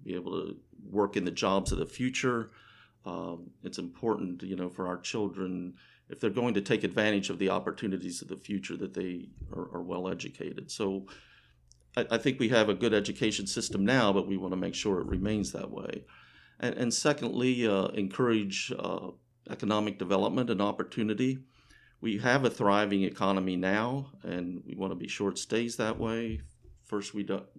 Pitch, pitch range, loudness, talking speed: 100 Hz, 95-115 Hz, -31 LUFS, 185 wpm